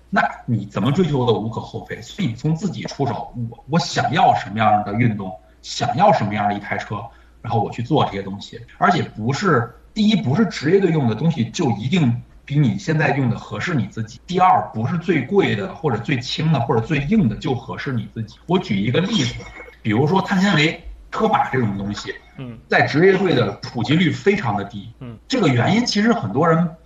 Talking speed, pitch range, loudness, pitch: 315 characters per minute, 115-170 Hz, -19 LUFS, 135 Hz